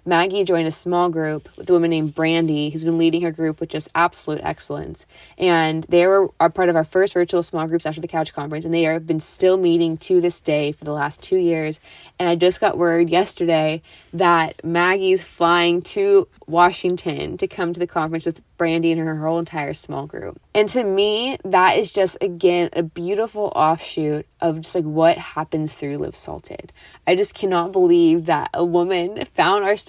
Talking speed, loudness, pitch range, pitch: 200 wpm, -19 LUFS, 160-180 Hz, 170 Hz